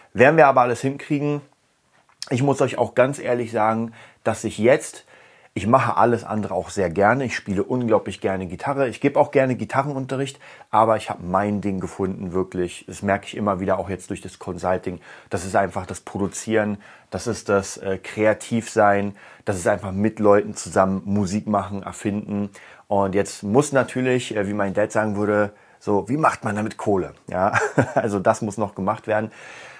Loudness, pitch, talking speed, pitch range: -22 LUFS, 105 Hz, 180 wpm, 100-115 Hz